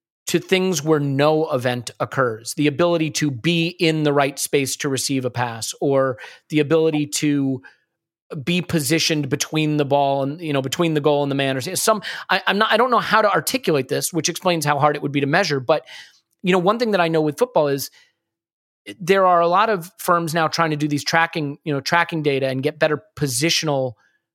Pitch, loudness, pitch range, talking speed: 150 Hz, -20 LUFS, 140-170 Hz, 215 wpm